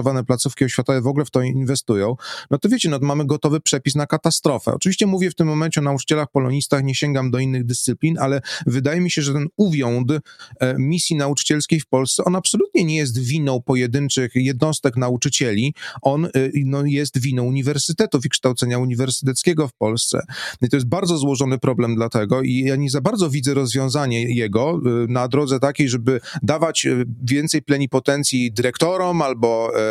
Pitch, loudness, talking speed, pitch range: 140 Hz, -19 LUFS, 175 wpm, 130-150 Hz